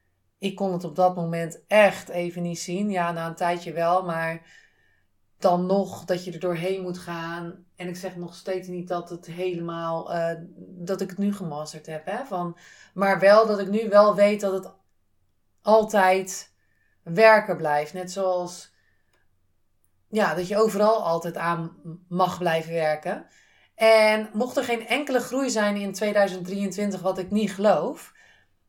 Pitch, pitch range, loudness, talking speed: 180 Hz, 170-200 Hz, -24 LUFS, 165 wpm